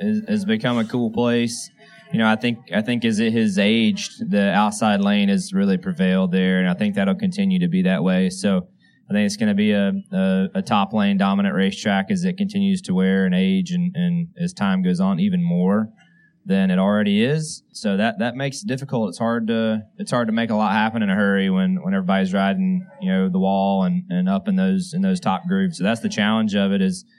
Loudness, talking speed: -20 LUFS, 235 wpm